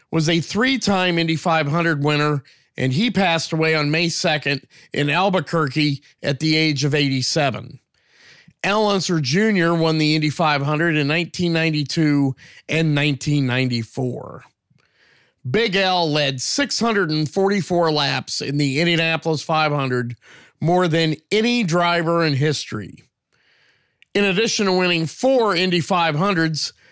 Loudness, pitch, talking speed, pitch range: -19 LUFS, 160 Hz, 120 wpm, 150-180 Hz